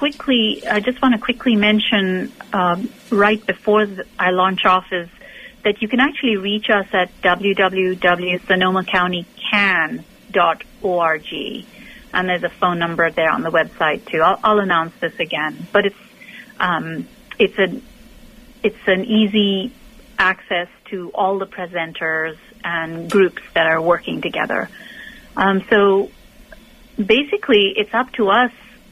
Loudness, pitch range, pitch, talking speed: -18 LUFS, 180-230 Hz, 200 Hz, 130 wpm